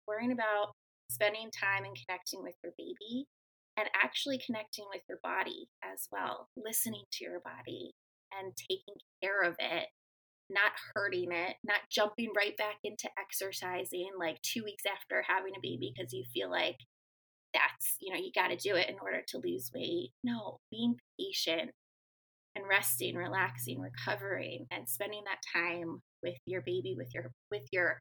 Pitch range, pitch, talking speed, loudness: 175-215 Hz, 195 Hz, 165 wpm, -36 LUFS